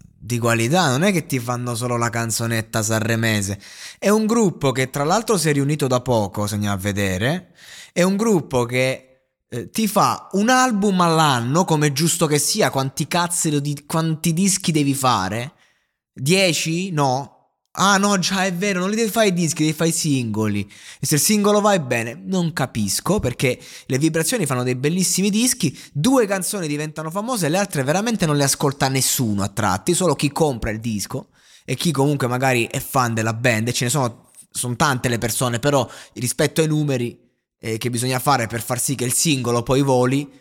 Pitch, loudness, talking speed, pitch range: 140 Hz, -19 LUFS, 195 wpm, 120-175 Hz